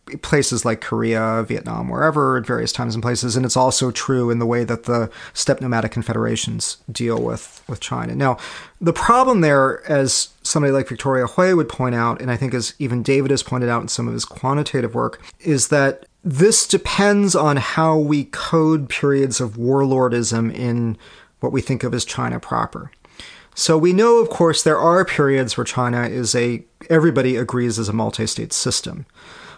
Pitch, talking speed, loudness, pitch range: 130 Hz, 185 wpm, -18 LUFS, 120-150 Hz